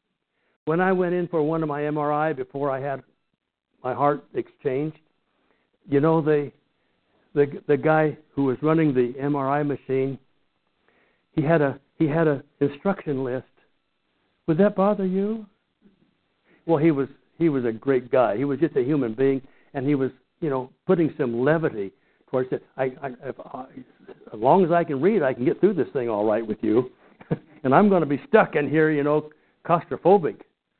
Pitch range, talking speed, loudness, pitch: 135-160 Hz, 185 wpm, -23 LUFS, 145 Hz